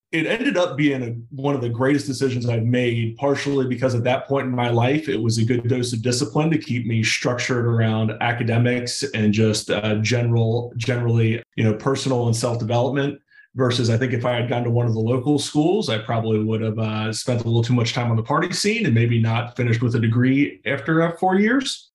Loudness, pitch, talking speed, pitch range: -21 LUFS, 120 Hz, 225 wpm, 115-140 Hz